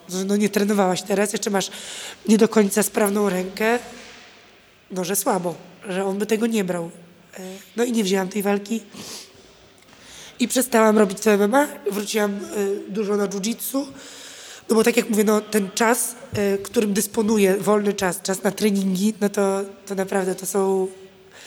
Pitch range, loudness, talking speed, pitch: 195-220 Hz, -21 LUFS, 155 wpm, 205 Hz